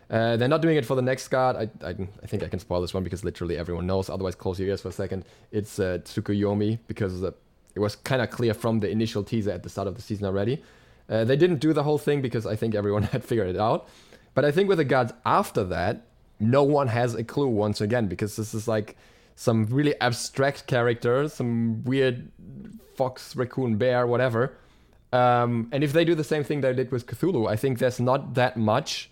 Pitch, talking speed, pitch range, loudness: 115 Hz, 230 wpm, 105-130 Hz, -25 LUFS